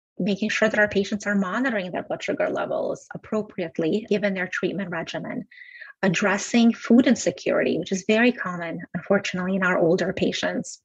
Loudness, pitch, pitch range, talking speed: -23 LUFS, 205 Hz, 185-220 Hz, 155 wpm